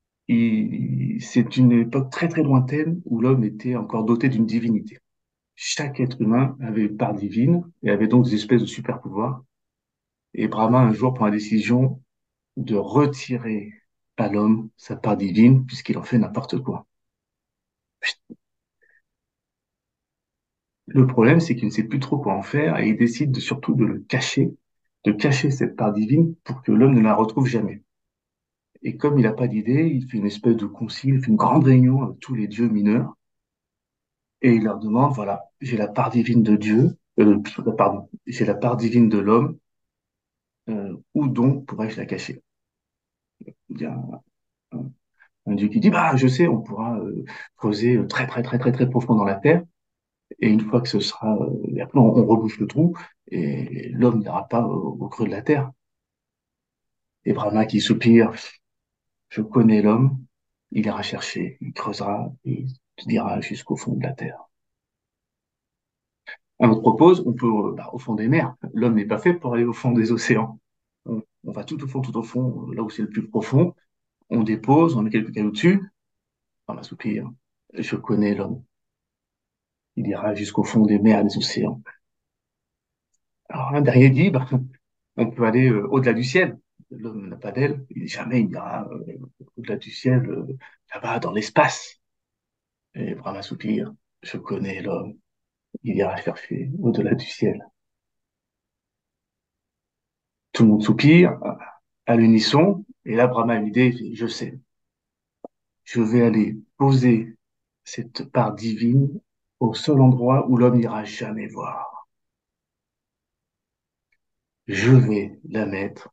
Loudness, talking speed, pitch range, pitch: -21 LUFS, 165 wpm, 110-130 Hz, 120 Hz